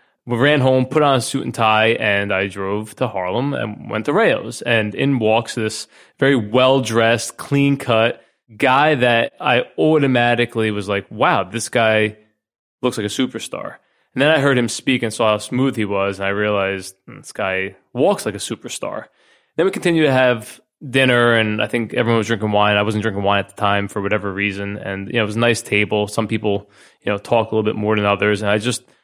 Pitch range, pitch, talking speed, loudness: 105-125 Hz, 110 Hz, 215 wpm, -18 LUFS